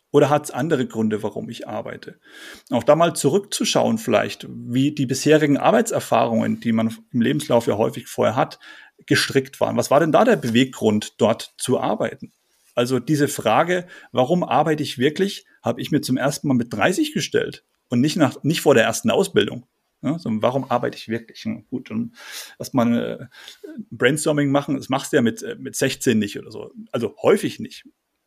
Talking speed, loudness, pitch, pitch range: 185 wpm, -21 LUFS, 140 Hz, 120-155 Hz